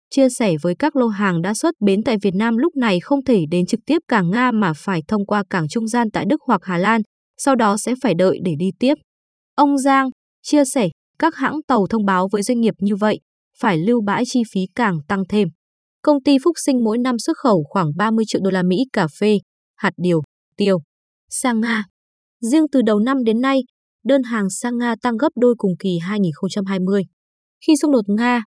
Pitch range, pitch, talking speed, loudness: 195-260 Hz, 225 Hz, 220 wpm, -18 LUFS